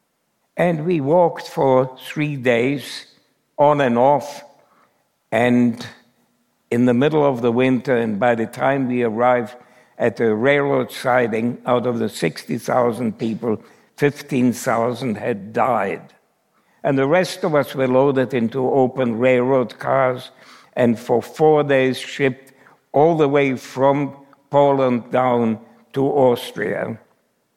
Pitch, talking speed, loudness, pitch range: 130 Hz, 125 wpm, -19 LUFS, 125-140 Hz